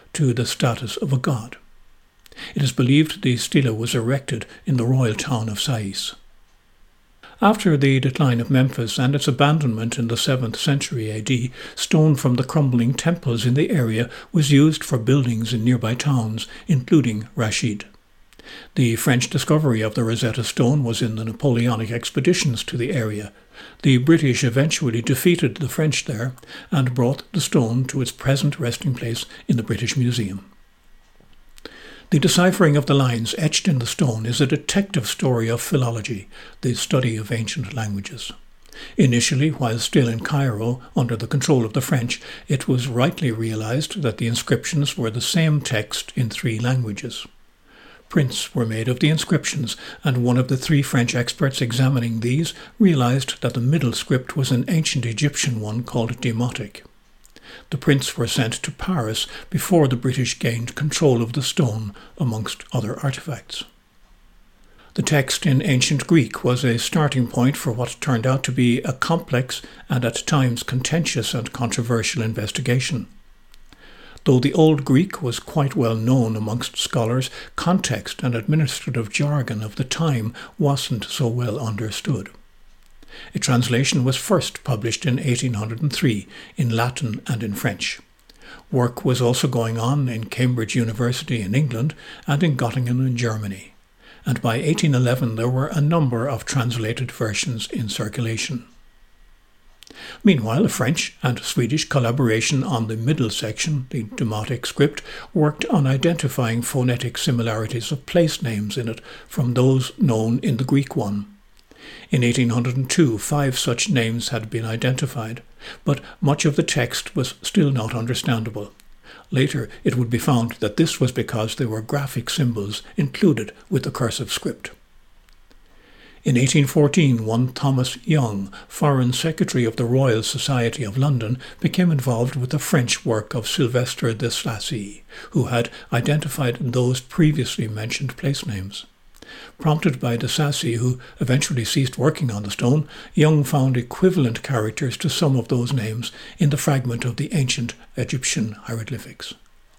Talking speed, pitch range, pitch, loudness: 155 wpm, 115-145 Hz, 125 Hz, -21 LUFS